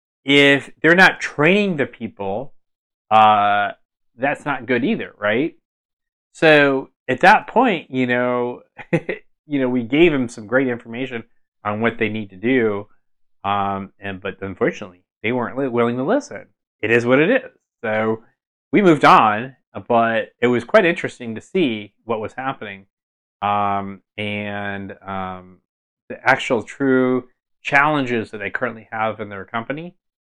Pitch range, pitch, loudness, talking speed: 100-130 Hz, 115 Hz, -18 LUFS, 145 wpm